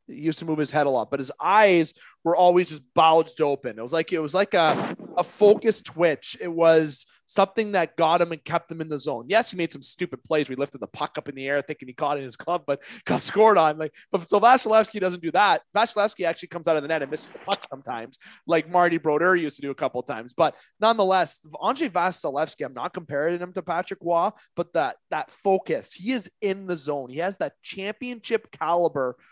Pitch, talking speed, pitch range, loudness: 165 Hz, 240 wpm, 150-190 Hz, -24 LUFS